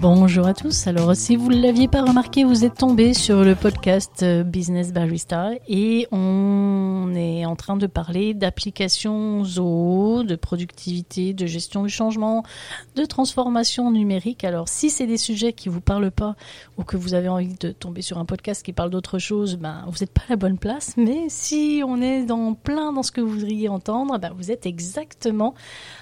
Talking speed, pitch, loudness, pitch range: 190 wpm, 200 Hz, -21 LUFS, 180-235 Hz